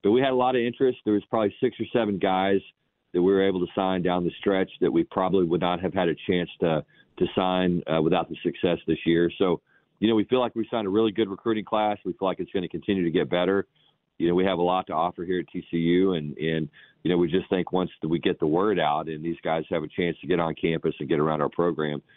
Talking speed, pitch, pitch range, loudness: 285 wpm, 95 Hz, 85-105 Hz, -25 LUFS